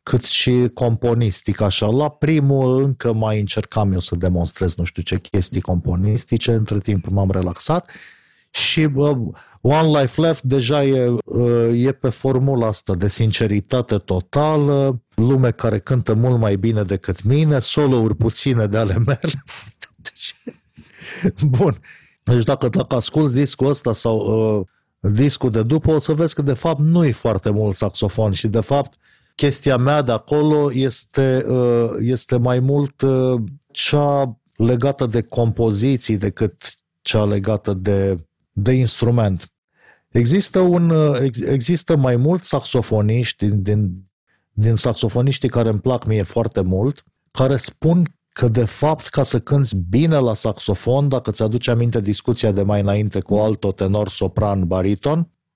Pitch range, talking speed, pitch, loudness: 105-135 Hz, 140 wpm, 120 Hz, -18 LUFS